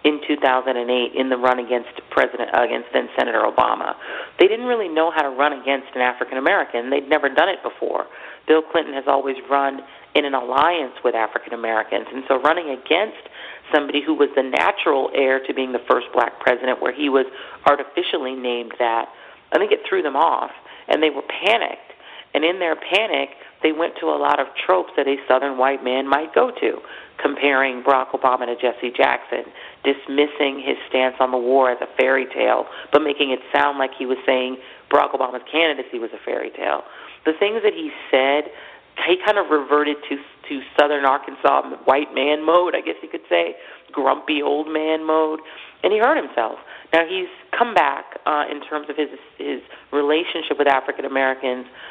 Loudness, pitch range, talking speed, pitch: -20 LUFS, 130-155 Hz, 190 wpm, 140 Hz